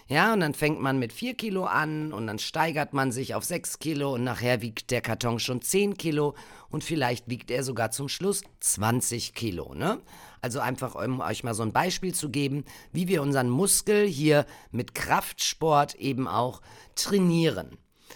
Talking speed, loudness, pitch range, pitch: 180 wpm, -27 LUFS, 120-160 Hz, 140 Hz